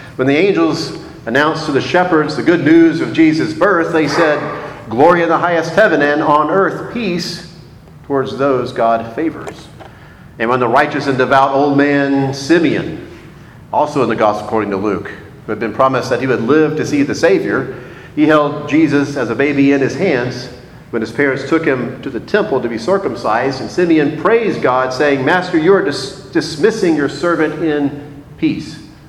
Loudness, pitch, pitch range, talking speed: -14 LUFS, 145 Hz, 130-160 Hz, 185 wpm